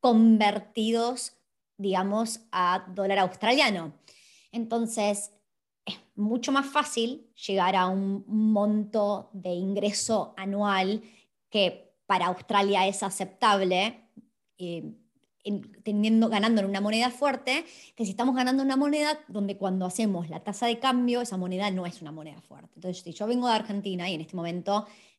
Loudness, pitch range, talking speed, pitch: -27 LUFS, 190-230 Hz, 145 wpm, 205 Hz